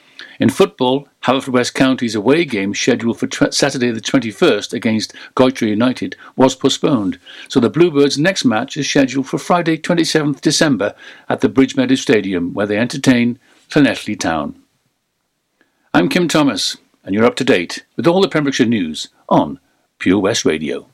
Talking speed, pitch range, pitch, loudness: 160 wpm, 120-155 Hz, 135 Hz, -16 LUFS